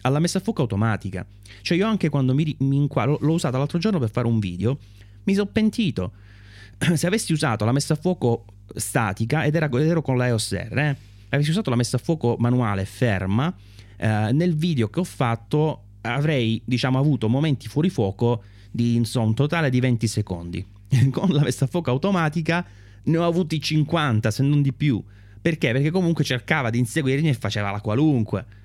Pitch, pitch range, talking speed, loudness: 130 Hz, 110-155 Hz, 180 wpm, -22 LUFS